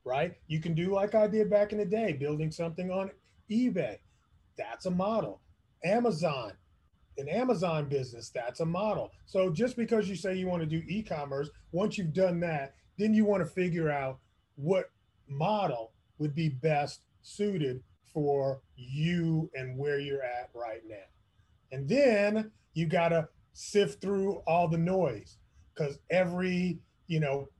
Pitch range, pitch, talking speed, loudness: 140-195 Hz, 165 Hz, 160 wpm, -31 LUFS